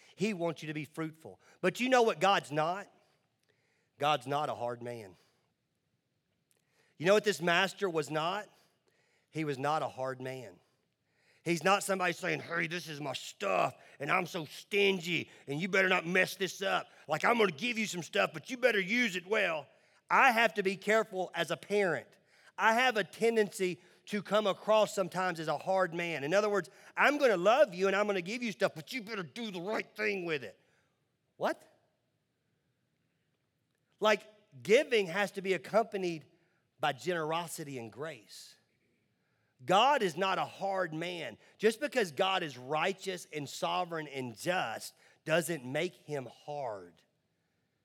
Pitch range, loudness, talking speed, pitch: 155-200 Hz, -32 LUFS, 170 wpm, 180 Hz